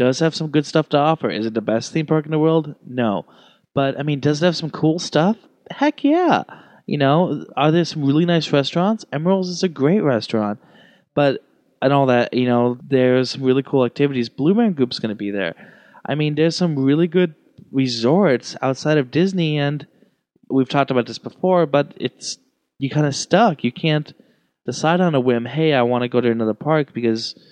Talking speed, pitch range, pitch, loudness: 210 wpm, 125-165 Hz, 145 Hz, -19 LUFS